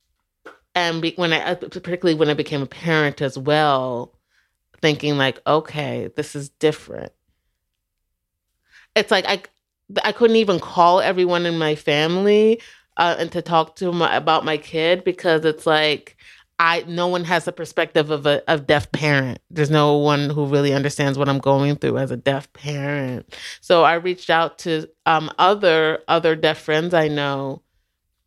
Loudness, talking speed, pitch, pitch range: -19 LUFS, 165 wpm, 155 Hz, 145-170 Hz